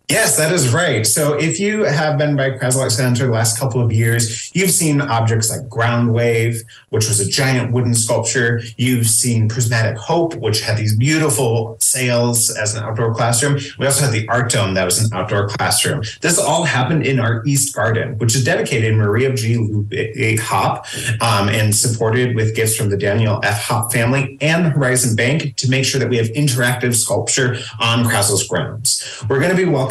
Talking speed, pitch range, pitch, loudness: 195 wpm, 115-135 Hz, 120 Hz, -16 LUFS